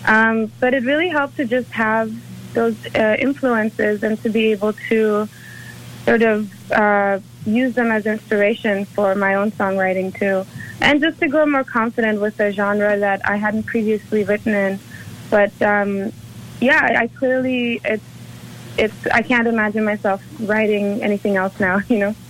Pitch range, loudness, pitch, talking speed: 205-230 Hz, -18 LUFS, 215 Hz, 165 wpm